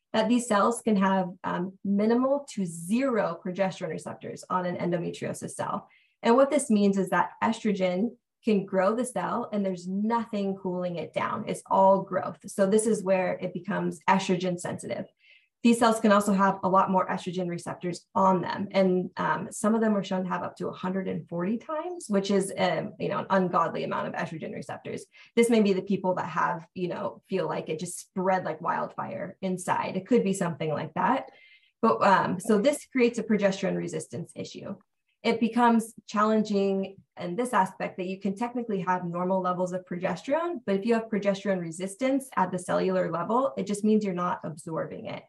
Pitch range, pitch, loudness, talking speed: 185-220 Hz, 195 Hz, -27 LUFS, 190 wpm